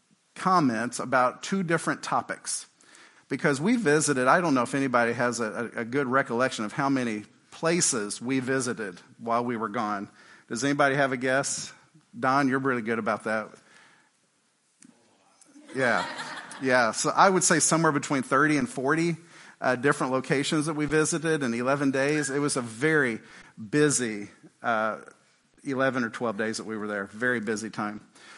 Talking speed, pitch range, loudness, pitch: 160 wpm, 120-150 Hz, -26 LUFS, 135 Hz